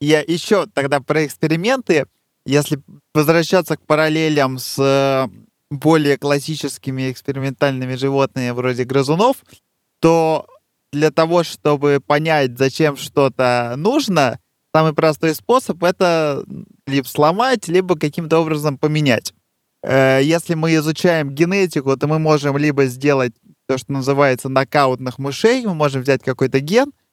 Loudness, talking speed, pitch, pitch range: -17 LUFS, 115 wpm, 150 Hz, 135-160 Hz